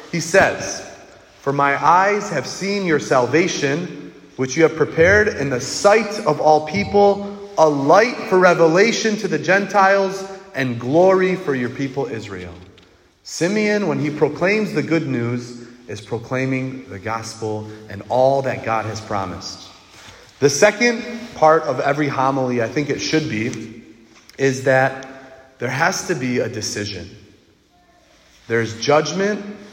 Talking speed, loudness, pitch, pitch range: 140 wpm, -18 LUFS, 140 Hz, 115-185 Hz